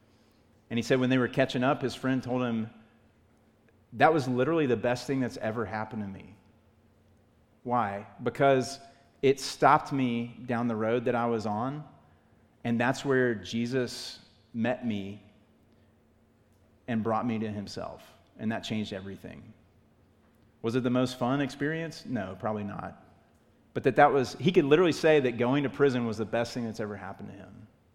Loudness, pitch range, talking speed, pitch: -29 LUFS, 110-130 Hz, 170 wpm, 115 Hz